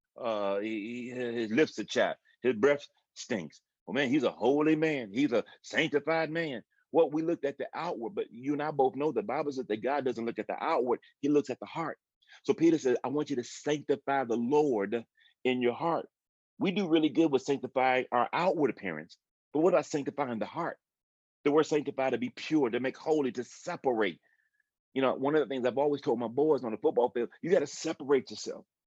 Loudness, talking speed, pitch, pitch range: -31 LUFS, 225 wpm, 145 Hz, 125-160 Hz